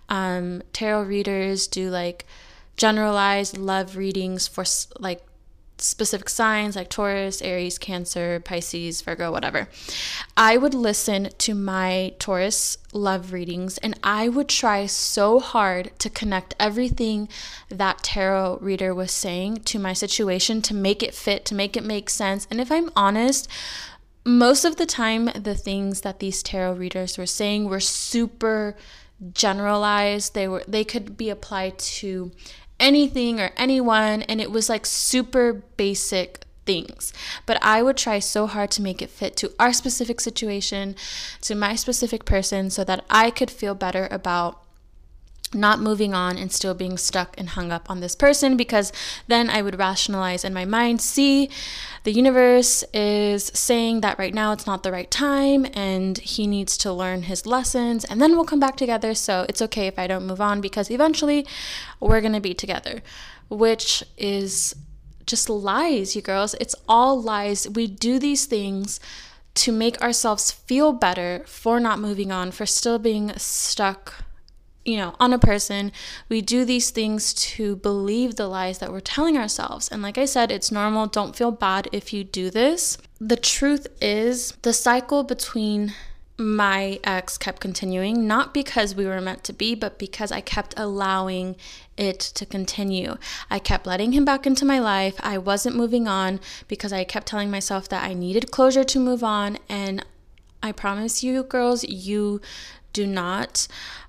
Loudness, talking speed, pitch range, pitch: -22 LUFS, 165 wpm, 190-235 Hz, 210 Hz